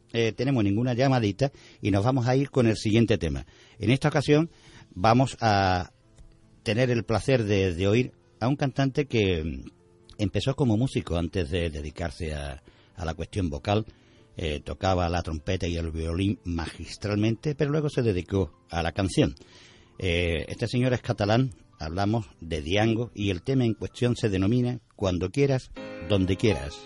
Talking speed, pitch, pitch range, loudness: 165 wpm, 105 Hz, 90-120 Hz, -26 LUFS